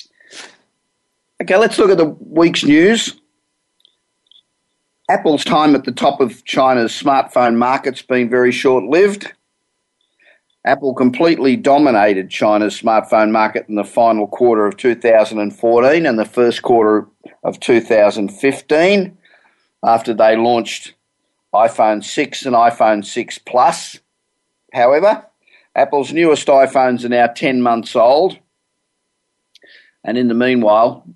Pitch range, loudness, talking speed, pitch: 110-140 Hz, -14 LUFS, 115 wpm, 125 Hz